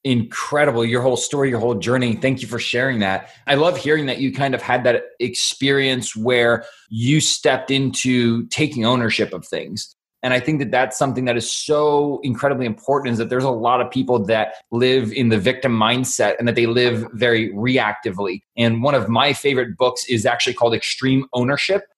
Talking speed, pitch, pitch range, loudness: 195 wpm, 125 Hz, 115-135 Hz, -19 LUFS